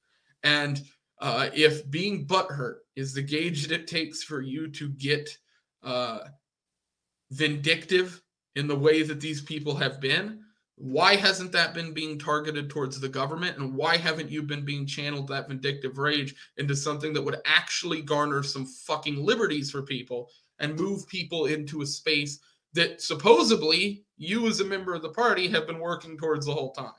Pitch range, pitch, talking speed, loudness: 140-170 Hz, 150 Hz, 170 wpm, -27 LUFS